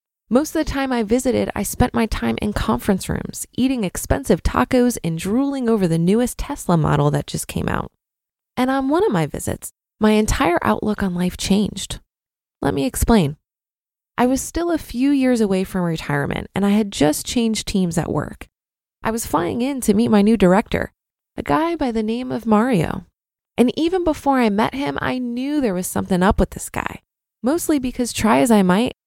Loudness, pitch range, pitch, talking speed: -19 LUFS, 180-250 Hz, 220 Hz, 200 wpm